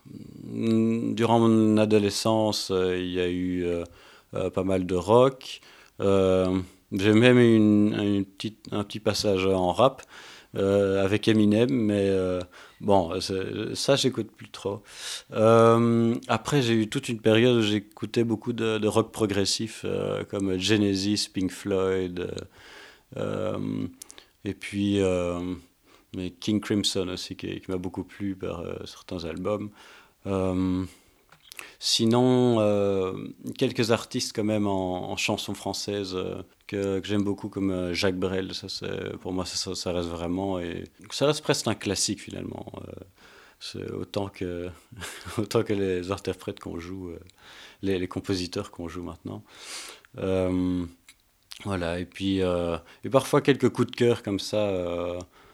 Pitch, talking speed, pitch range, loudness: 100 Hz, 145 wpm, 95-110 Hz, -26 LUFS